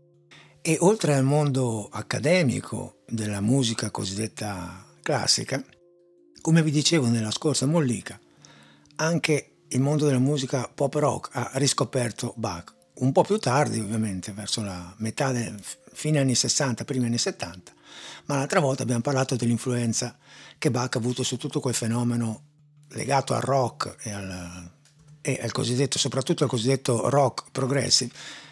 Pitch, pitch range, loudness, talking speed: 130 Hz, 115-150 Hz, -25 LUFS, 140 wpm